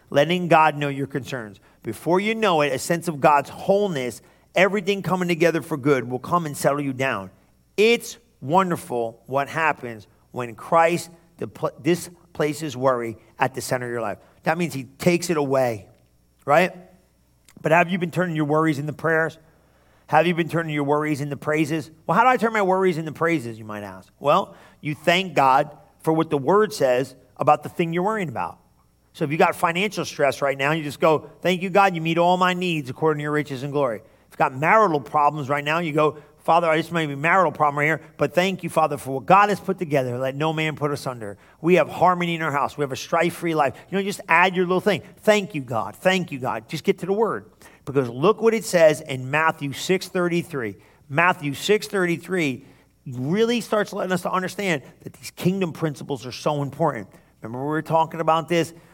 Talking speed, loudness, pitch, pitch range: 210 wpm, -22 LUFS, 155 Hz, 135-175 Hz